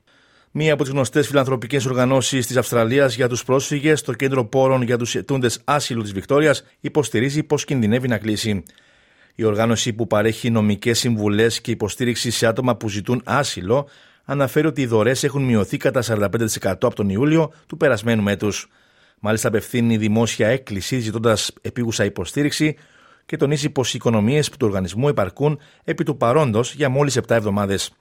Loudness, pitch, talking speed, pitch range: -20 LUFS, 120 Hz, 160 wpm, 110-140 Hz